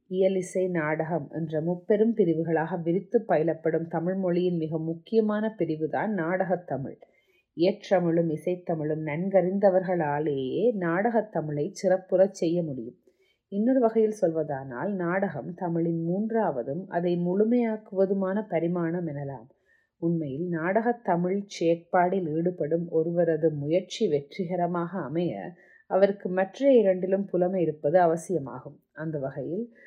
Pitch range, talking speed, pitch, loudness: 165-195 Hz, 100 wpm, 180 Hz, -27 LUFS